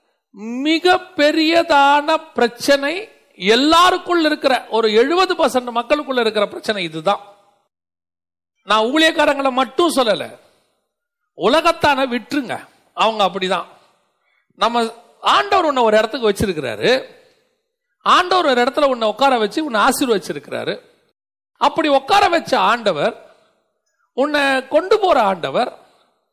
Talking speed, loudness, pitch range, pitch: 90 wpm, -16 LUFS, 225-330 Hz, 280 Hz